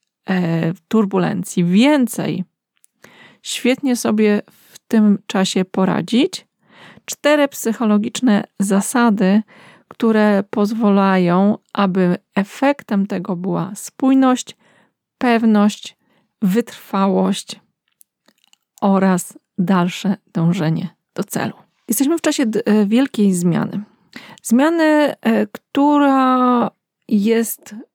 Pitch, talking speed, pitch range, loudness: 210 Hz, 70 wpm, 195-240 Hz, -17 LUFS